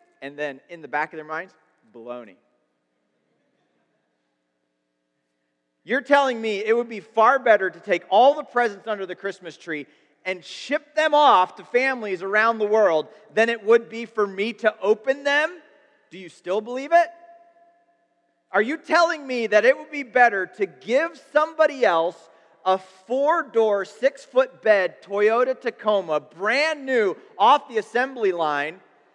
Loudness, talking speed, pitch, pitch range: -22 LUFS, 155 wpm, 215 Hz, 170-275 Hz